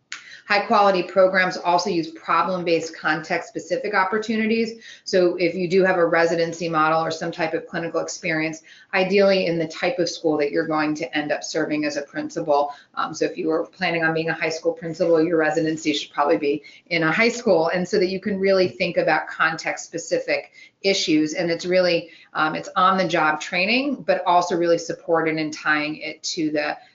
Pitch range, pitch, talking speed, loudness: 160-185 Hz, 170 Hz, 185 wpm, -21 LUFS